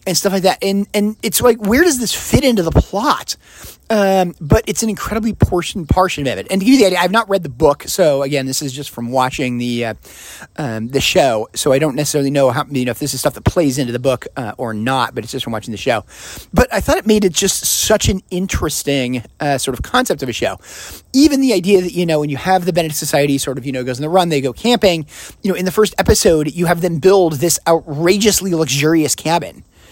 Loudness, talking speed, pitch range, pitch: -15 LUFS, 255 wpm, 135-195 Hz, 160 Hz